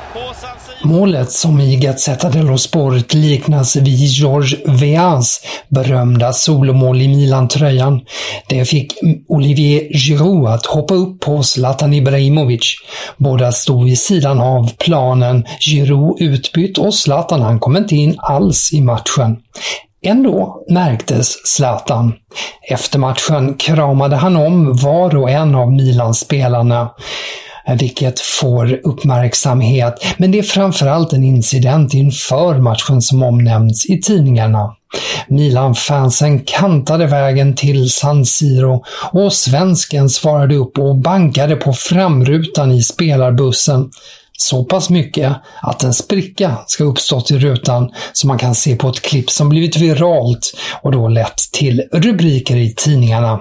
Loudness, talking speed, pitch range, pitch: -12 LUFS, 125 wpm, 125-155 Hz, 140 Hz